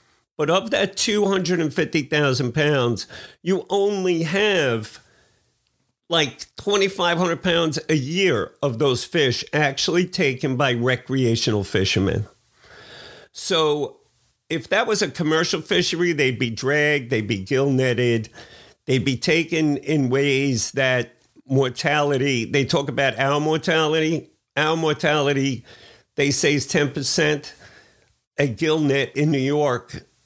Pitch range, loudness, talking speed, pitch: 130-165 Hz, -21 LUFS, 115 wpm, 145 Hz